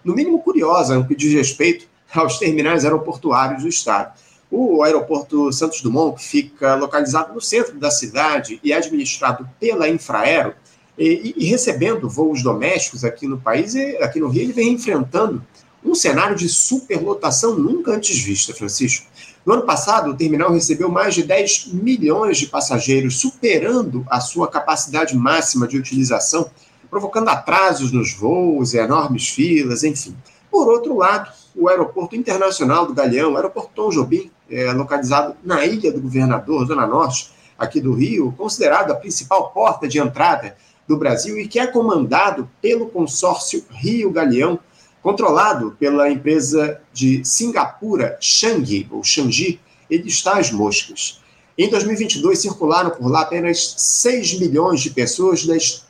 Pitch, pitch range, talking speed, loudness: 165 Hz, 140-230 Hz, 145 wpm, -17 LUFS